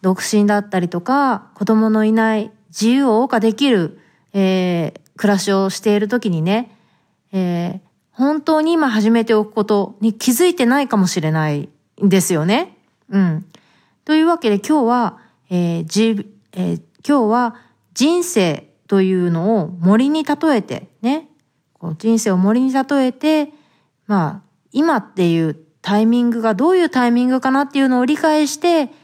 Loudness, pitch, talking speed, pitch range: -17 LUFS, 220 Hz, 295 characters per minute, 185-260 Hz